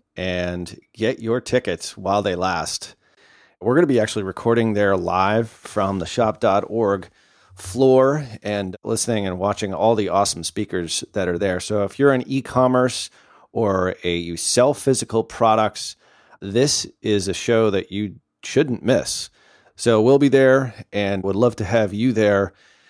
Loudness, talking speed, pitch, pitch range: -20 LUFS, 160 wpm, 105 Hz, 95-120 Hz